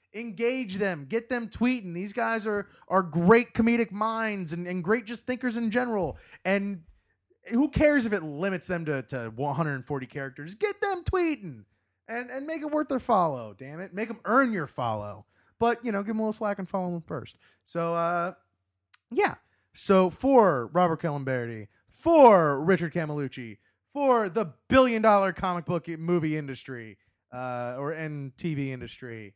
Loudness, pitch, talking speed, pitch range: -27 LUFS, 180 Hz, 170 wpm, 140-230 Hz